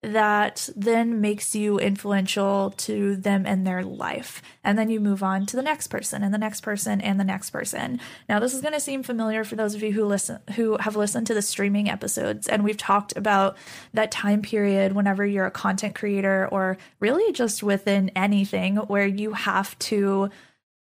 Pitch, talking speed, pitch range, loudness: 205 Hz, 195 wpm, 195-215 Hz, -24 LUFS